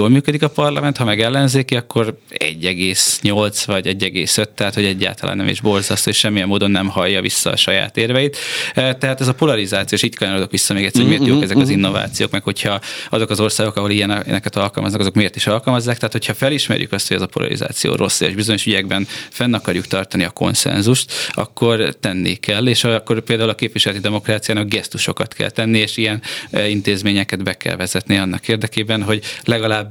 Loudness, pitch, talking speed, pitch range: -16 LUFS, 105 Hz, 185 wpm, 100-115 Hz